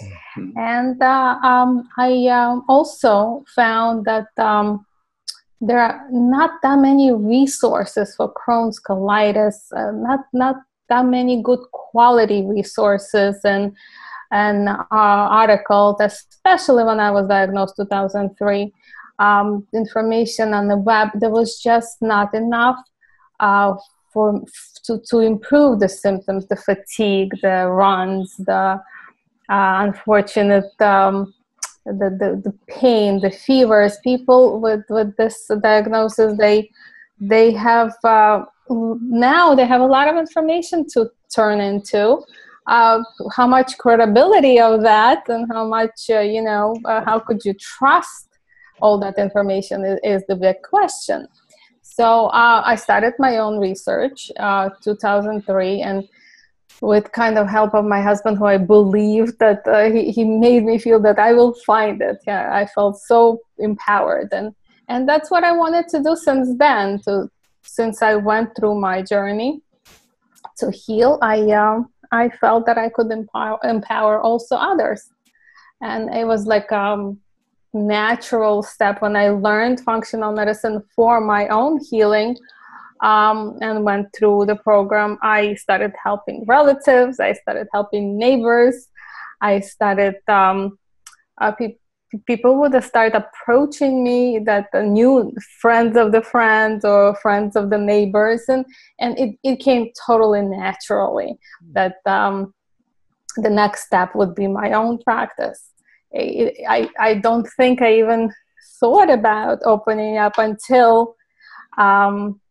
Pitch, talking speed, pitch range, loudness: 220 Hz, 145 wpm, 205-245 Hz, -16 LUFS